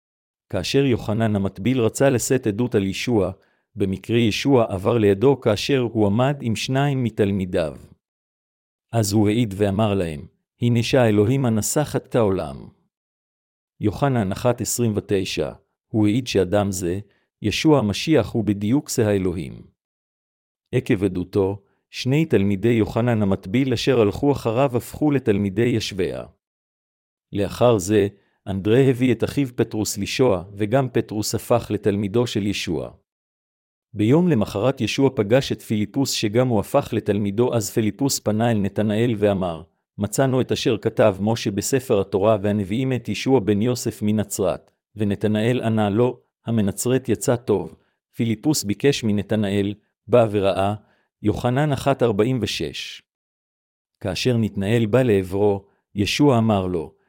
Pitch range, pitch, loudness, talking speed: 100-125 Hz, 110 Hz, -21 LUFS, 120 wpm